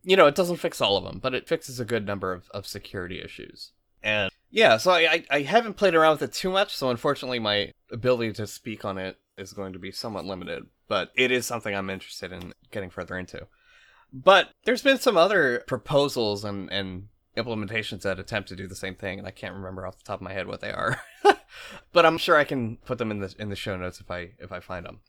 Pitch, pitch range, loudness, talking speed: 110 Hz, 95-140 Hz, -25 LUFS, 245 wpm